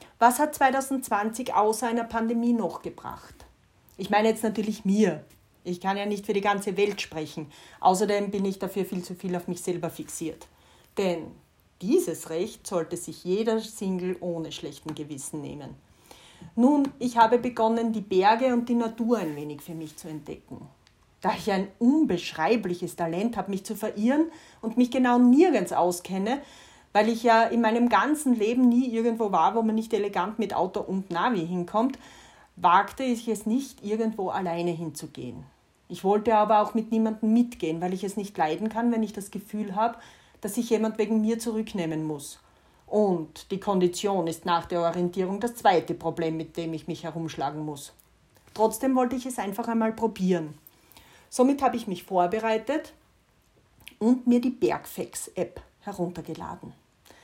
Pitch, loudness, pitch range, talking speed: 205 Hz, -26 LUFS, 175-230 Hz, 165 wpm